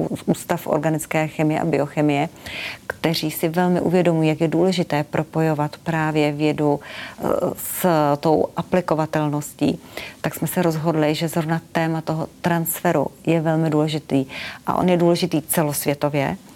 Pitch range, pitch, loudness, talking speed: 150-170 Hz, 160 Hz, -21 LUFS, 130 wpm